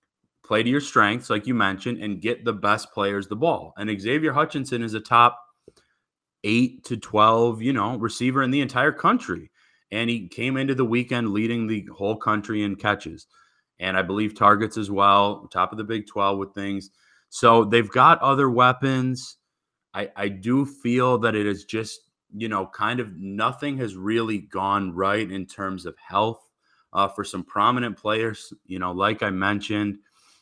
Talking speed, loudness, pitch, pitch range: 180 wpm, -23 LUFS, 110 Hz, 100-120 Hz